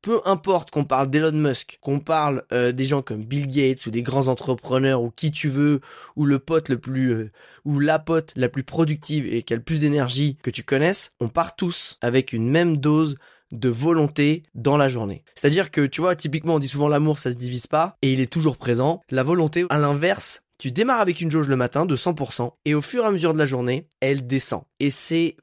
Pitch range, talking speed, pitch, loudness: 130-160 Hz, 235 wpm, 145 Hz, -22 LUFS